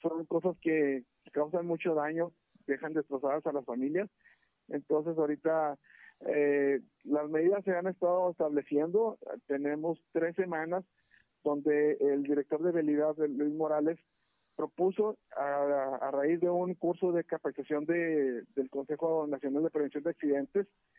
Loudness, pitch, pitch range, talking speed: -32 LUFS, 155 Hz, 145-170 Hz, 135 wpm